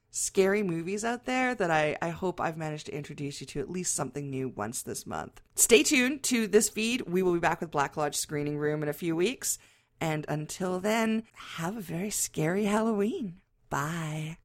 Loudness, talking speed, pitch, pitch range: -29 LUFS, 200 wpm, 165 Hz, 150-205 Hz